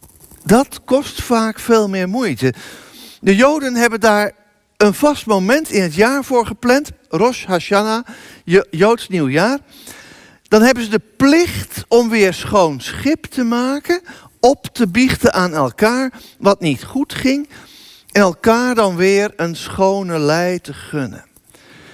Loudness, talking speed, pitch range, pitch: -15 LUFS, 140 wpm, 185-250 Hz, 220 Hz